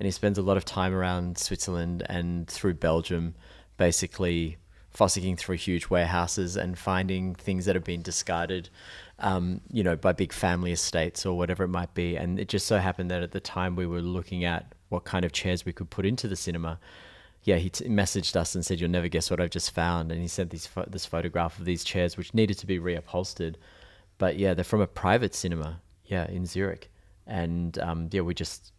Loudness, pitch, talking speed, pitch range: -29 LUFS, 90 Hz, 215 wpm, 85-95 Hz